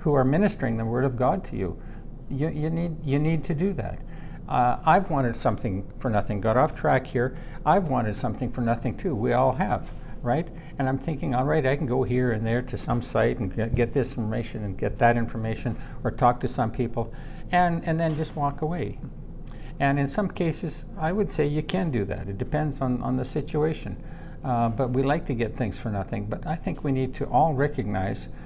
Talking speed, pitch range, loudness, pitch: 220 wpm, 120-155 Hz, -26 LUFS, 130 Hz